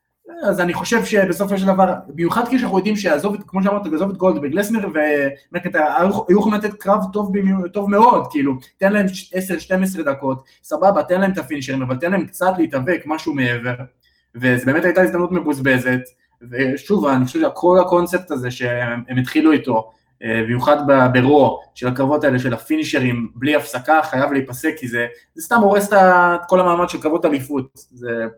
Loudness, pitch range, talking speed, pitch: -17 LUFS, 130-190 Hz, 165 wpm, 155 Hz